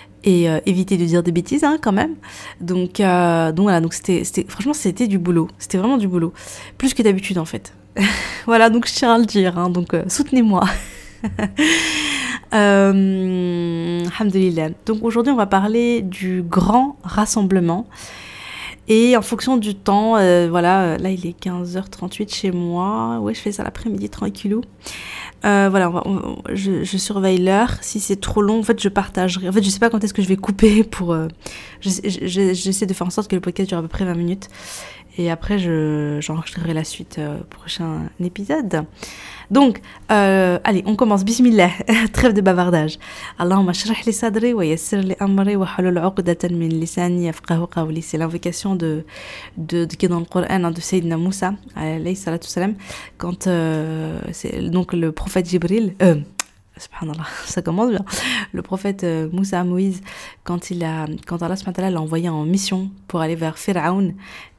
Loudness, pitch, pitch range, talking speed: -19 LUFS, 185 Hz, 170-205 Hz, 180 wpm